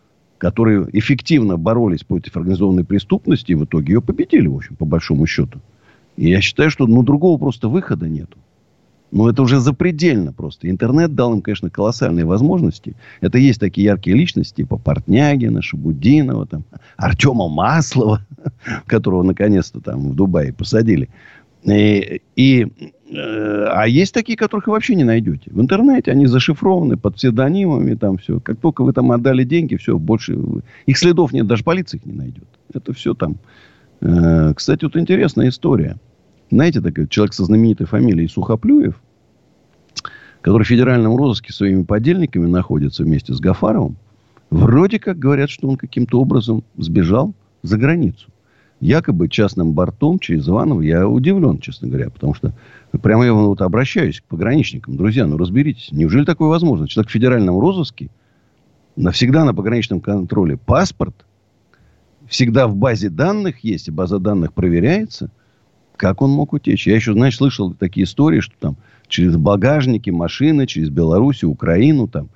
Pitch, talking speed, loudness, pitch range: 115 Hz, 155 wpm, -15 LUFS, 100-145 Hz